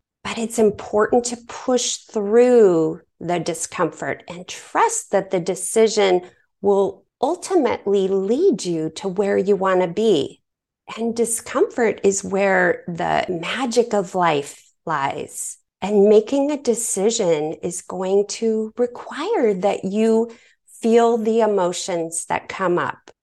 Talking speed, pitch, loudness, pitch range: 125 wpm, 205 Hz, -20 LUFS, 180-230 Hz